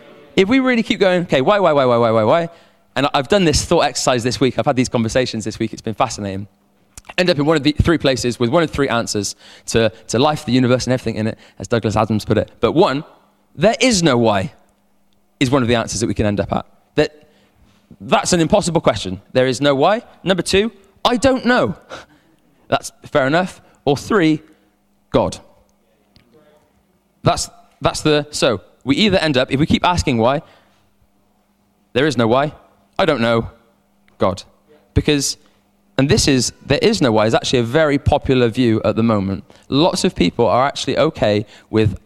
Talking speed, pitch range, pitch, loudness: 200 wpm, 105-150 Hz, 125 Hz, -17 LUFS